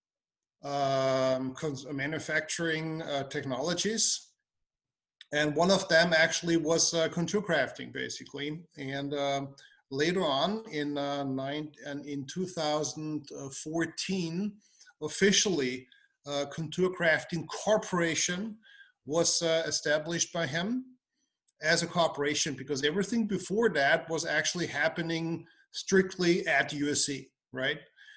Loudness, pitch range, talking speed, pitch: -30 LUFS, 145-180 Hz, 105 wpm, 160 Hz